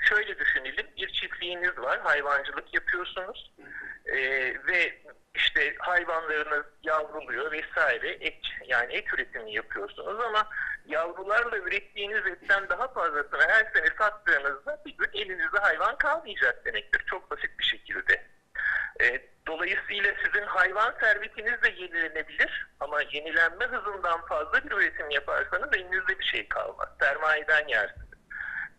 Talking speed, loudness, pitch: 120 wpm, -27 LUFS, 210 Hz